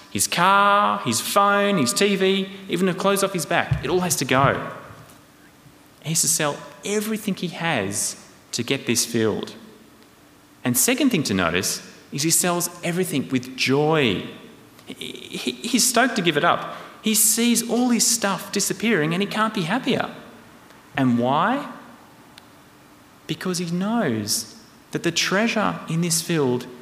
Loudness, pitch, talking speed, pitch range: -21 LUFS, 180 Hz, 150 wpm, 140-210 Hz